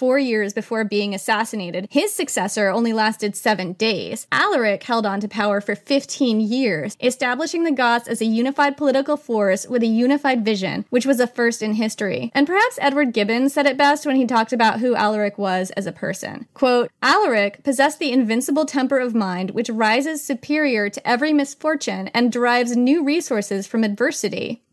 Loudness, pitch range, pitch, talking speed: -20 LUFS, 210-275 Hz, 235 Hz, 180 wpm